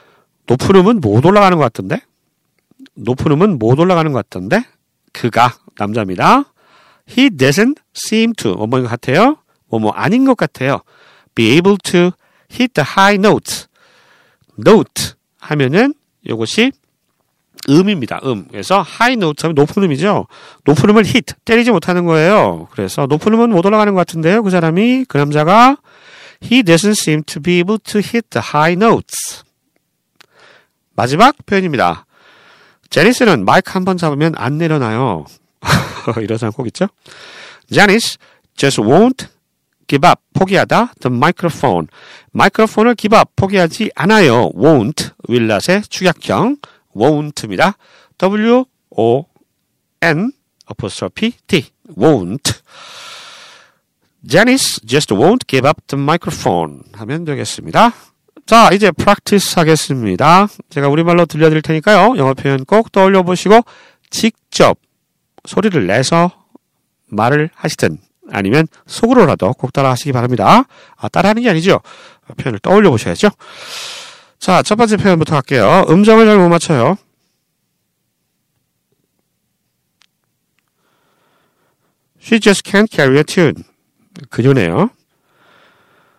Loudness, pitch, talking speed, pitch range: -12 LUFS, 180 Hz, 340 characters per minute, 140-220 Hz